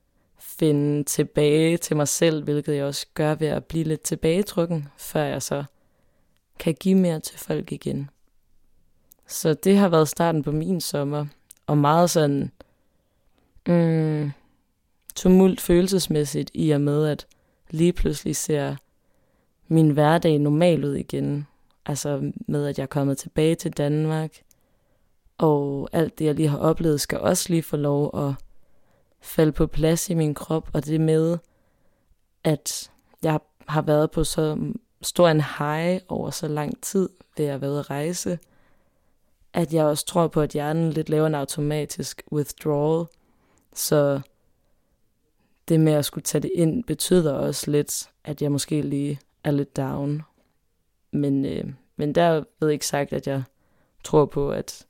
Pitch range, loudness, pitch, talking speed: 145-165 Hz, -23 LUFS, 155 Hz, 155 wpm